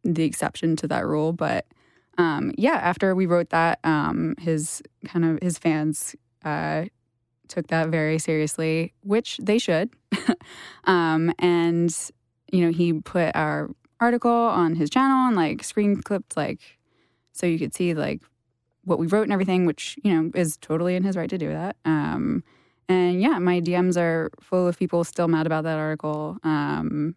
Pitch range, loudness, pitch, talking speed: 155-185 Hz, -24 LUFS, 170 Hz, 170 wpm